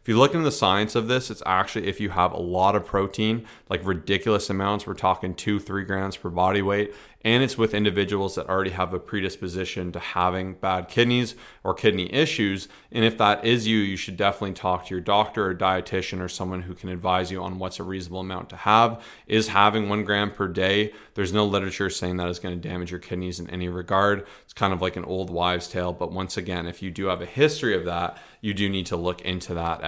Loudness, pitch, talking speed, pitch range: -25 LUFS, 95 Hz, 235 wpm, 90-105 Hz